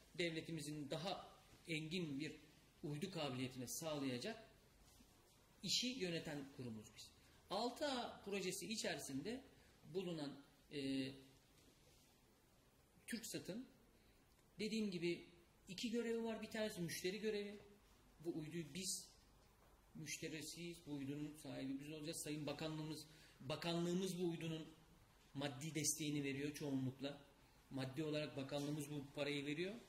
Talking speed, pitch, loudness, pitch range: 100 wpm, 155 Hz, -47 LUFS, 145-185 Hz